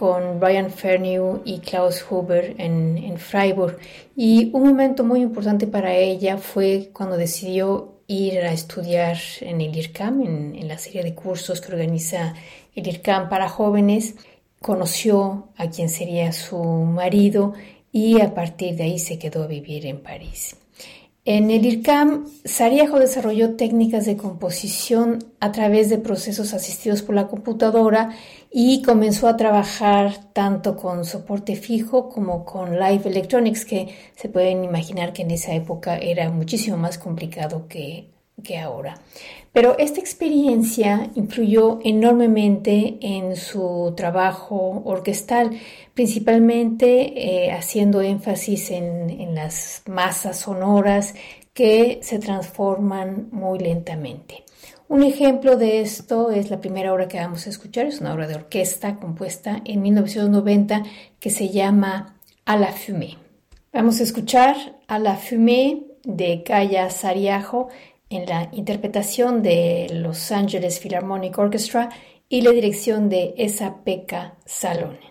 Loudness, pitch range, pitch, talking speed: -20 LUFS, 180-225 Hz, 200 Hz, 135 wpm